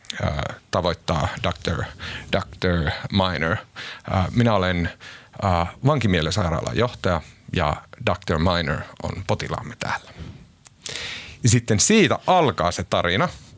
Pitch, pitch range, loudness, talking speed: 95 Hz, 85-110 Hz, -22 LUFS, 90 wpm